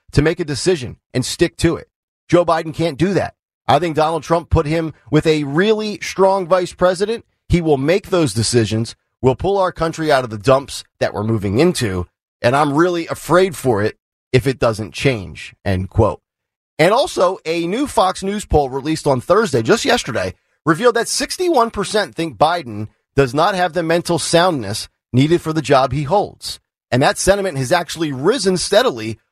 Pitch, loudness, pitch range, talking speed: 160 Hz, -17 LUFS, 130-180 Hz, 185 wpm